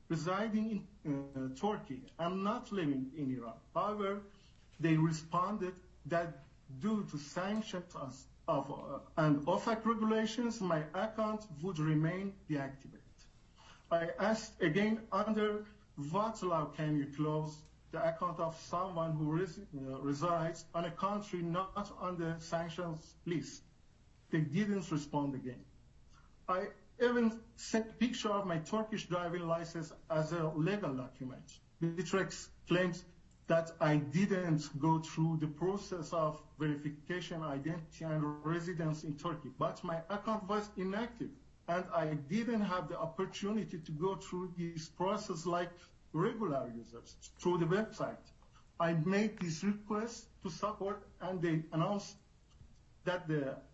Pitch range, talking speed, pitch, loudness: 155-200 Hz, 130 wpm, 175 Hz, -37 LUFS